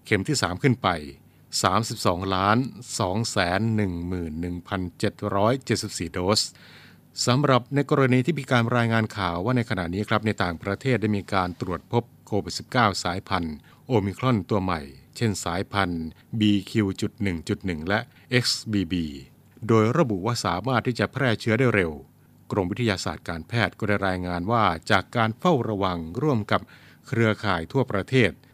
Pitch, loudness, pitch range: 105 Hz, -25 LUFS, 90-120 Hz